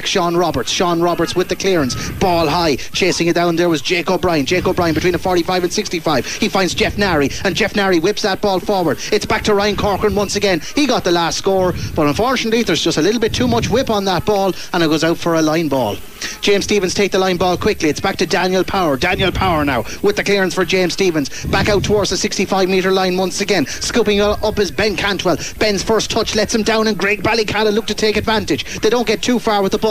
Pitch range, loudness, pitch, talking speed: 175-210 Hz, -16 LUFS, 195 Hz, 245 wpm